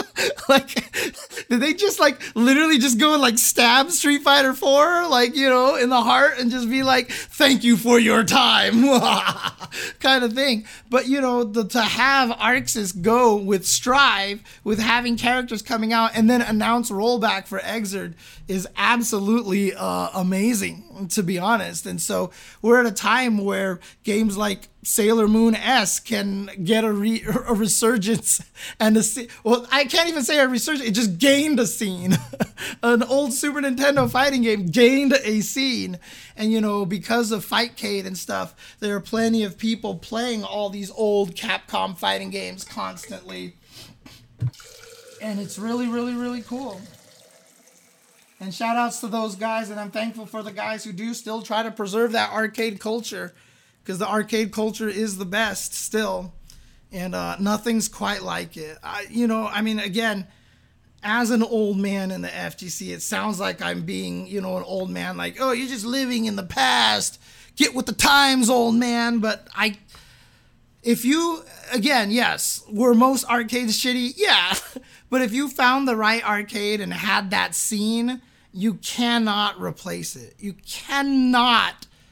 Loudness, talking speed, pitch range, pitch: -20 LUFS, 165 wpm, 205-250 Hz, 225 Hz